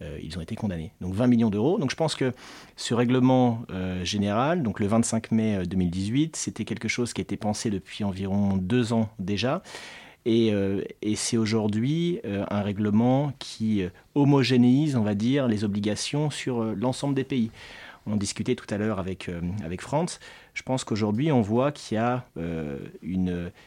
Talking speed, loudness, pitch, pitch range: 185 wpm, -26 LUFS, 110 Hz, 100-125 Hz